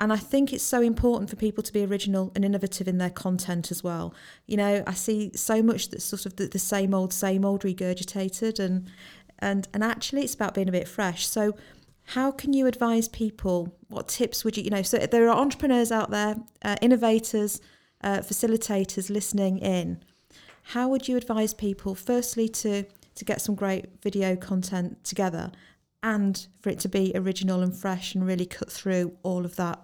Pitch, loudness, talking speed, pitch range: 200 Hz, -27 LUFS, 195 wpm, 190-220 Hz